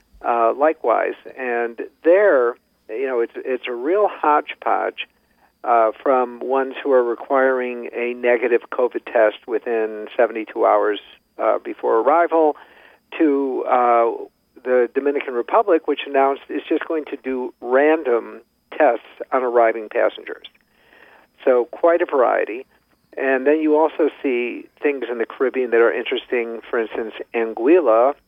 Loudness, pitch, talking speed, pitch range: -19 LUFS, 130 Hz, 135 wpm, 120-165 Hz